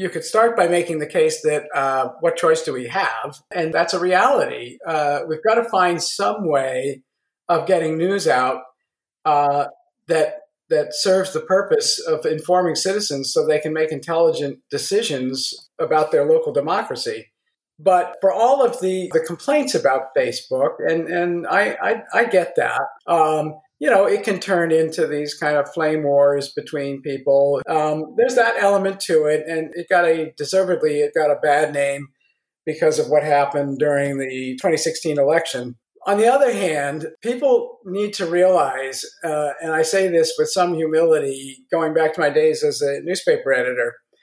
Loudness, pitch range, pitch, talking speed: -19 LUFS, 150-230 Hz, 170 Hz, 170 wpm